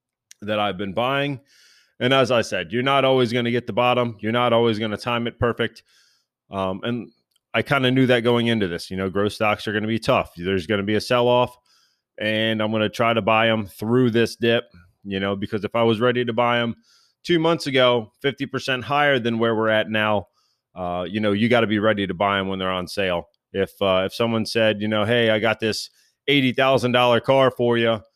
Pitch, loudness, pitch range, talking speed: 115 Hz, -21 LUFS, 105-125 Hz, 235 wpm